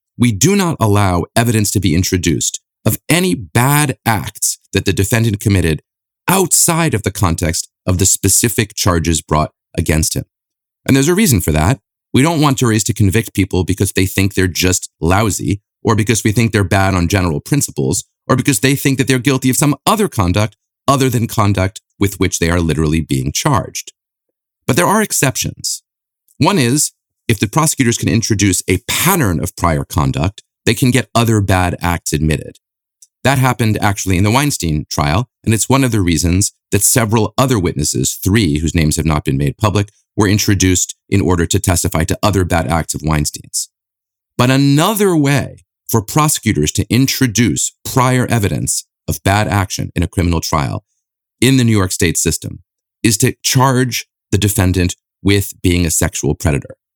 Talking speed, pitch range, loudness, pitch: 180 wpm, 90-125 Hz, -14 LUFS, 105 Hz